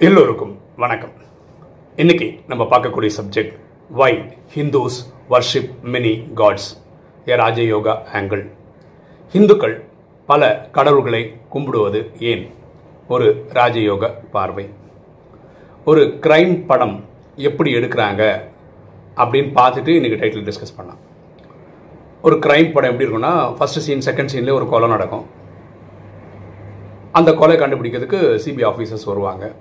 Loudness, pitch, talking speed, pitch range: -16 LUFS, 120 Hz, 105 wpm, 105-140 Hz